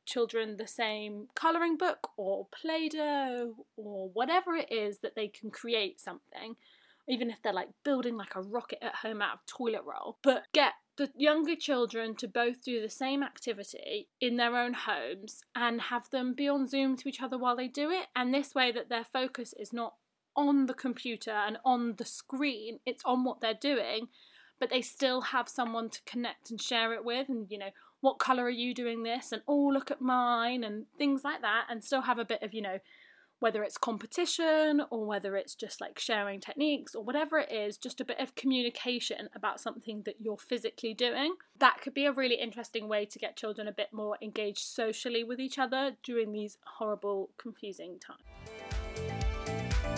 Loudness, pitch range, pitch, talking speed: -33 LUFS, 220-270 Hz, 240 Hz, 195 wpm